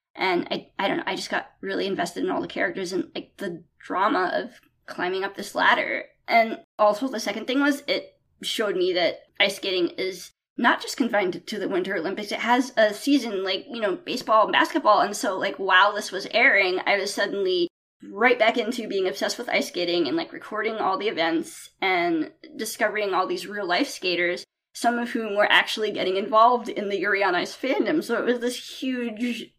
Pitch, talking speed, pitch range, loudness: 230 Hz, 205 wpm, 200-305 Hz, -24 LUFS